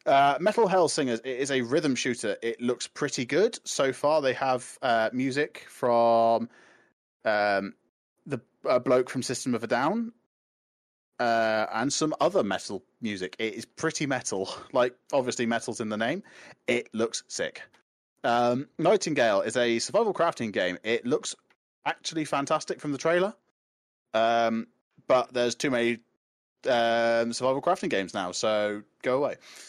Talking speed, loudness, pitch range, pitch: 150 wpm, -27 LUFS, 115-135 Hz, 120 Hz